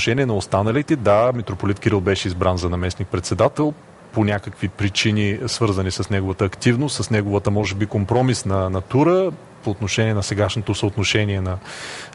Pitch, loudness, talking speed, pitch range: 105 Hz, -20 LUFS, 145 wpm, 100-115 Hz